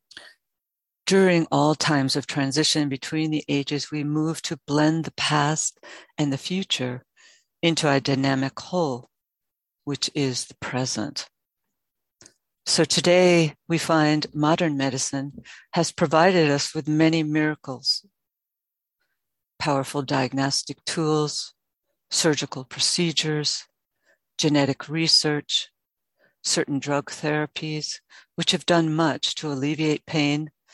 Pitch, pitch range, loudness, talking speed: 150 Hz, 140-160 Hz, -23 LUFS, 105 wpm